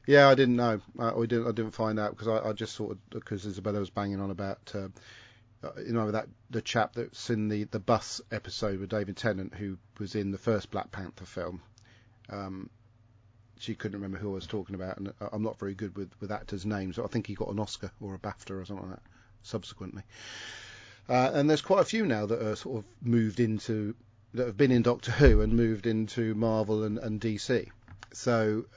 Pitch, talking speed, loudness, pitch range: 110 Hz, 215 wpm, -30 LUFS, 100-115 Hz